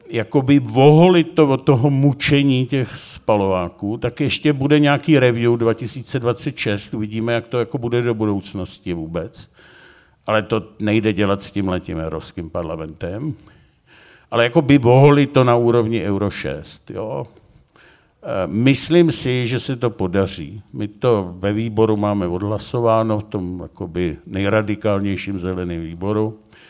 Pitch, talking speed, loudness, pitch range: 110 Hz, 125 wpm, -18 LUFS, 100-130 Hz